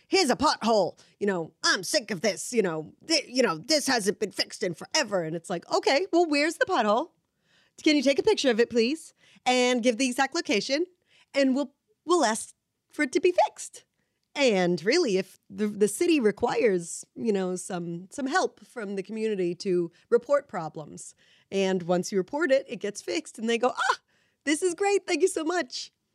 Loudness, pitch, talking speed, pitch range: -26 LUFS, 240 Hz, 200 wpm, 195-310 Hz